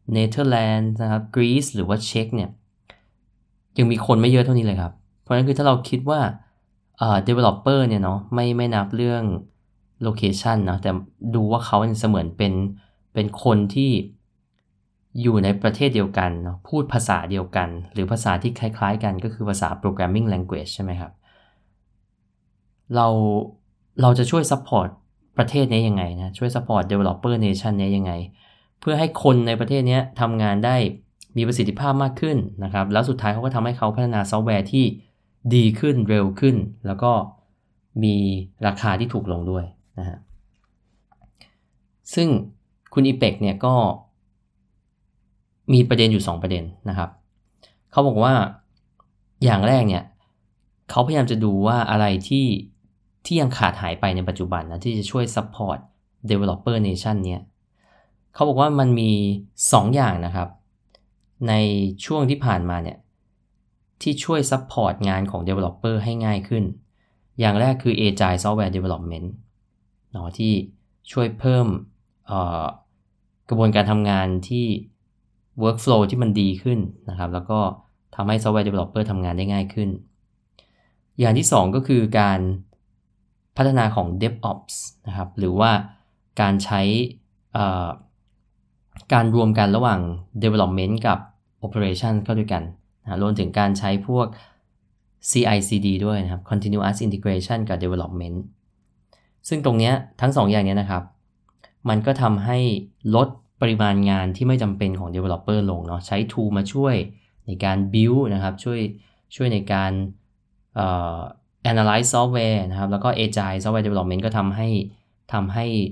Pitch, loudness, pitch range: 105 Hz, -21 LUFS, 100-115 Hz